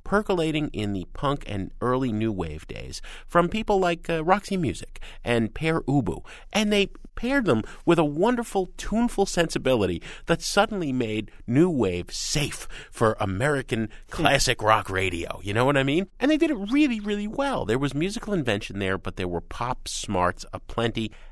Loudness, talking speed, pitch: -25 LUFS, 170 wpm, 140 Hz